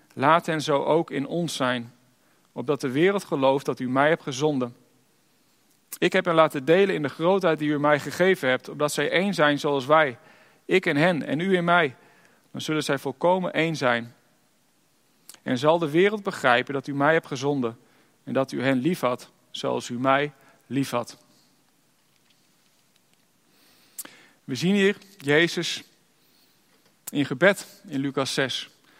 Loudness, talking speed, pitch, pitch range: -24 LUFS, 160 wpm, 145 Hz, 135-170 Hz